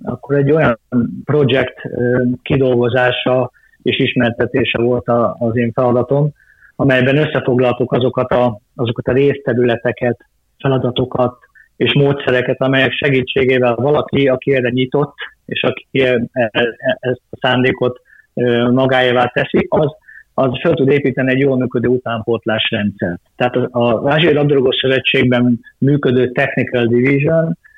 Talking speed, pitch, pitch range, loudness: 110 wpm, 125 Hz, 125-135 Hz, -15 LUFS